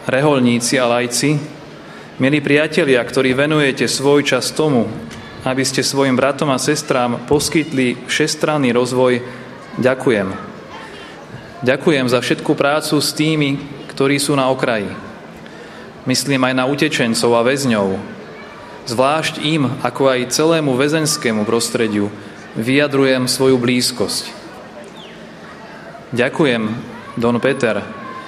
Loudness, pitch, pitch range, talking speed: -16 LUFS, 130 Hz, 125-150 Hz, 105 wpm